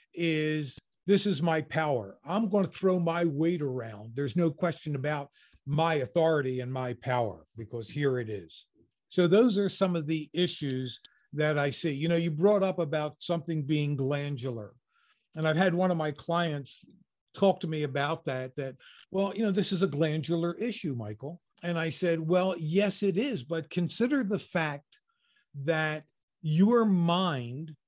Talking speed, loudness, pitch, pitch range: 170 wpm, -29 LUFS, 160 Hz, 145-185 Hz